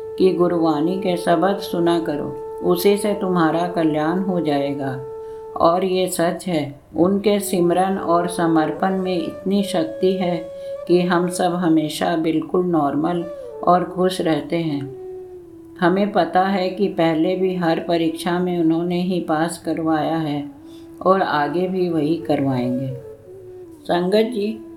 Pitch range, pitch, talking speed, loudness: 160-190 Hz, 175 Hz, 135 wpm, -20 LUFS